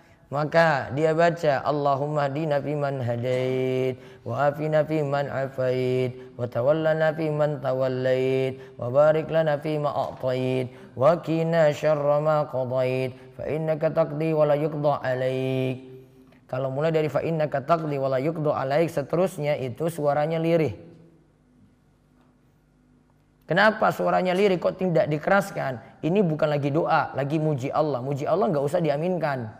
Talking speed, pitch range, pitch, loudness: 130 wpm, 130-155 Hz, 145 Hz, -24 LUFS